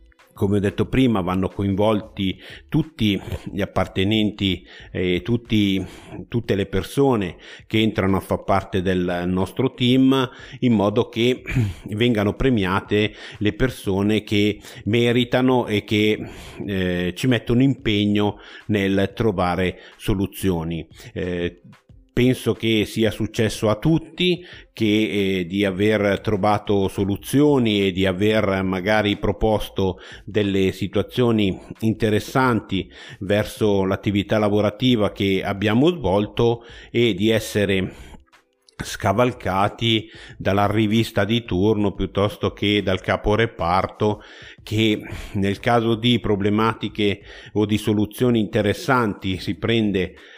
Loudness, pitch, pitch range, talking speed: -21 LUFS, 105 Hz, 95-115 Hz, 105 wpm